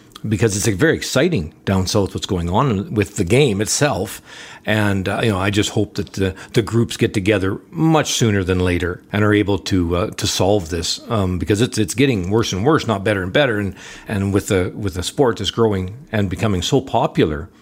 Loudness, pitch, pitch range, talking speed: -18 LUFS, 105 Hz, 95-110 Hz, 220 wpm